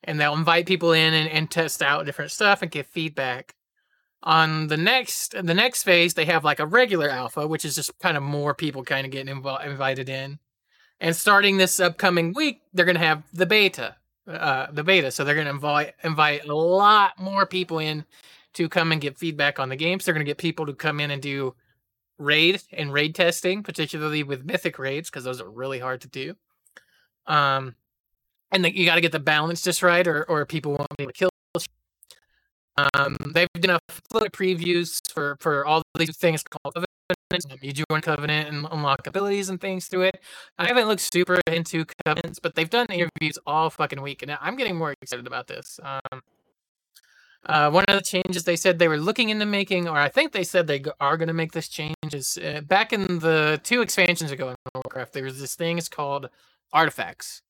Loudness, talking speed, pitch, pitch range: -23 LUFS, 215 wpm, 160 Hz, 145-180 Hz